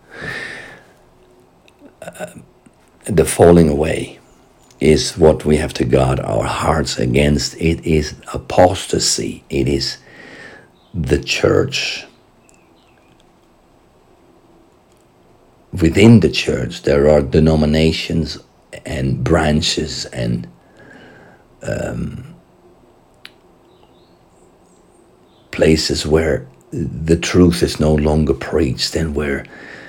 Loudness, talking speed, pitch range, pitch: -16 LUFS, 80 wpm, 70-80 Hz, 75 Hz